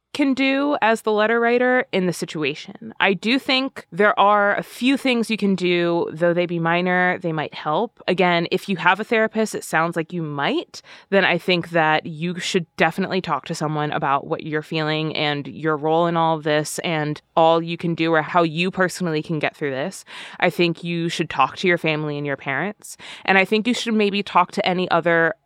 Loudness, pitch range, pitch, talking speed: -20 LUFS, 160-200 Hz, 175 Hz, 220 wpm